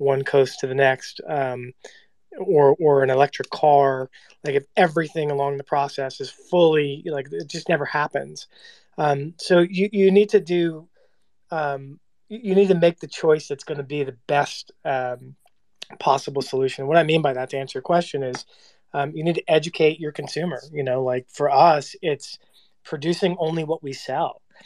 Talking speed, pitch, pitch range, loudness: 185 wpm, 145 Hz, 135-170 Hz, -22 LUFS